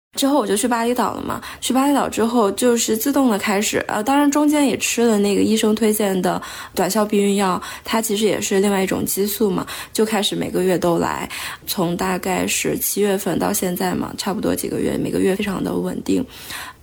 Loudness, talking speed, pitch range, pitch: -19 LUFS, 315 characters per minute, 195-235 Hz, 210 Hz